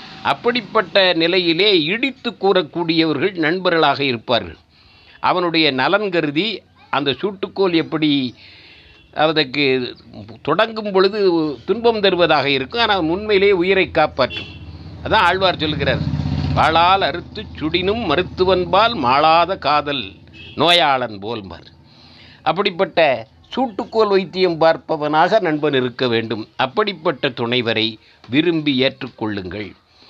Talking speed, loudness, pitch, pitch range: 90 wpm, -17 LUFS, 155 Hz, 115-190 Hz